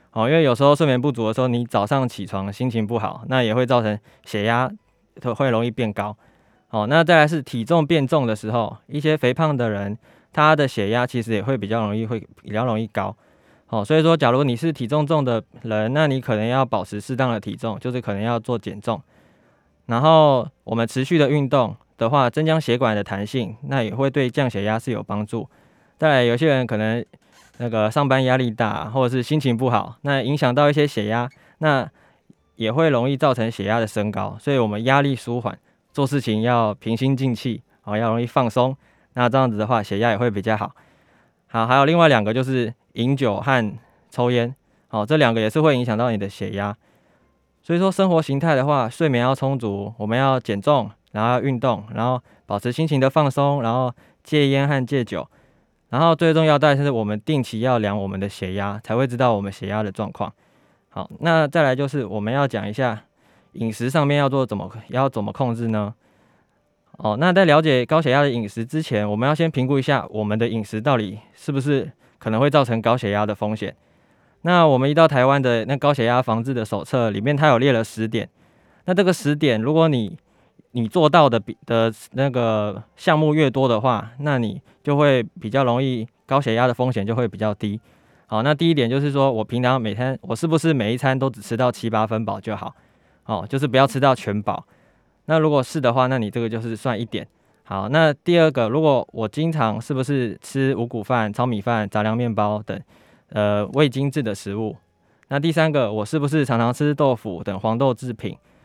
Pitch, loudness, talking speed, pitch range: 125 Hz, -20 LUFS, 300 characters per minute, 110-140 Hz